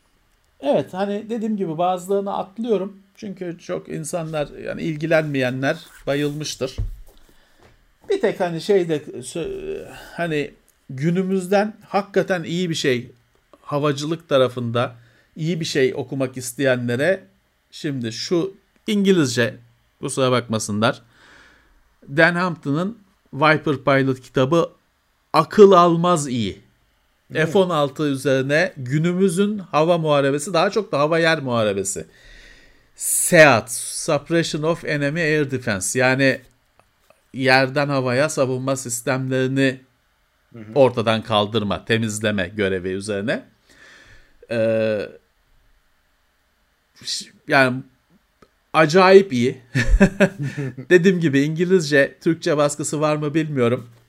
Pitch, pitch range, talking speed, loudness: 145 Hz, 125-175 Hz, 90 wpm, -20 LUFS